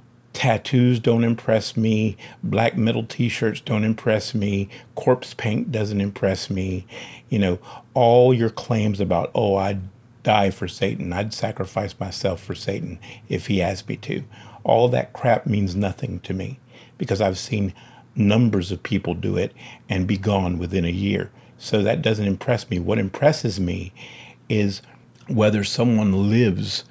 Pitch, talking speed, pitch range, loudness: 105 Hz, 155 wpm, 95-120 Hz, -22 LUFS